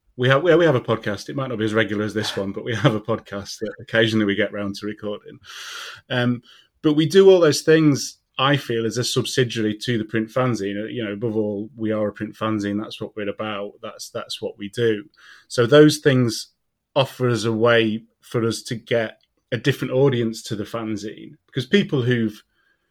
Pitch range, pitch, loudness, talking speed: 105-130 Hz, 115 Hz, -21 LUFS, 210 wpm